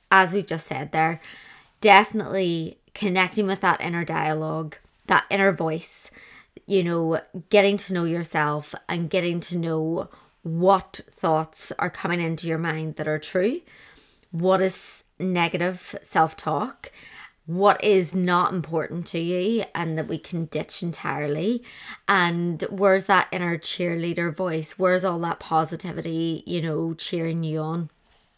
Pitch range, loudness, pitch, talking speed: 160-190 Hz, -24 LUFS, 170 Hz, 140 wpm